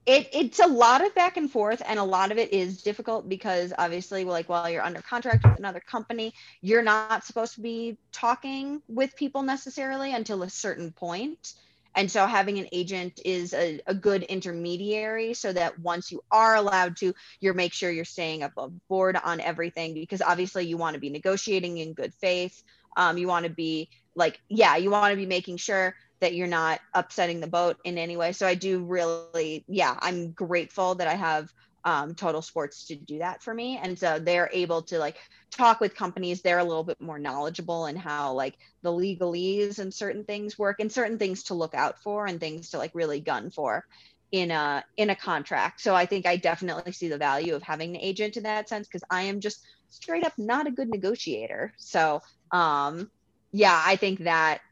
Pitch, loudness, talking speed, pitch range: 185 Hz, -27 LUFS, 205 wpm, 170-210 Hz